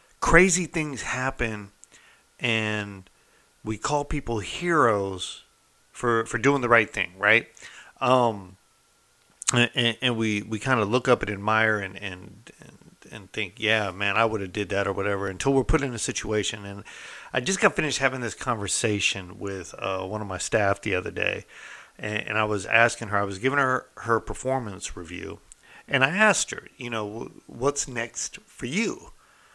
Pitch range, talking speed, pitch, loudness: 100-130 Hz, 170 wpm, 110 Hz, -25 LUFS